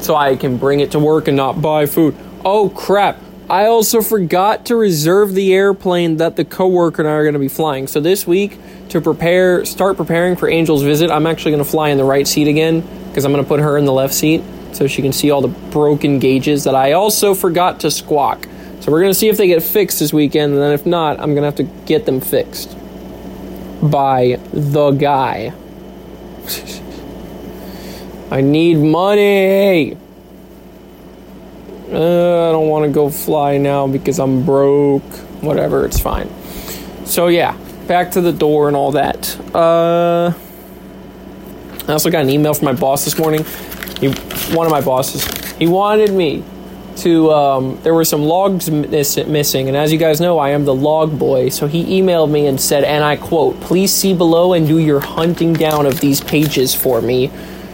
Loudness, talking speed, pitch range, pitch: -14 LUFS, 190 wpm, 145-175 Hz, 155 Hz